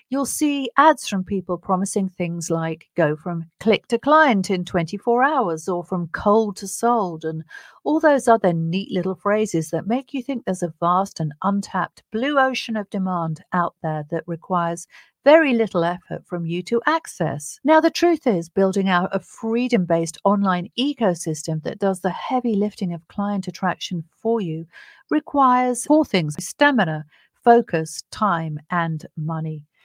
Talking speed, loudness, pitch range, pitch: 165 wpm, -21 LUFS, 170-235 Hz, 190 Hz